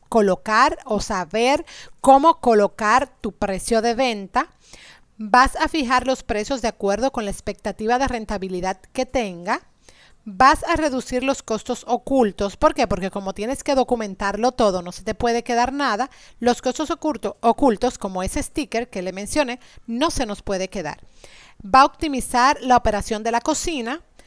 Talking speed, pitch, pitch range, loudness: 165 wpm, 240 Hz, 210-265 Hz, -21 LUFS